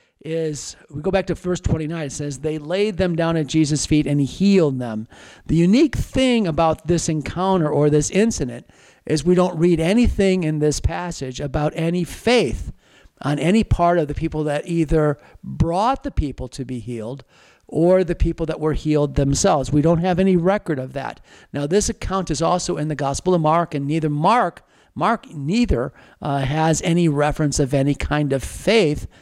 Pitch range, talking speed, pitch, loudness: 145-180 Hz, 185 wpm, 160 Hz, -20 LUFS